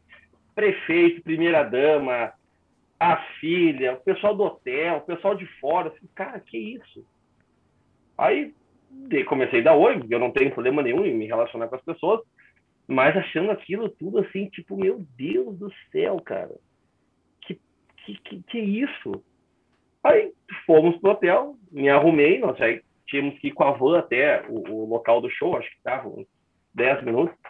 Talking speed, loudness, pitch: 170 wpm, -23 LUFS, 195 Hz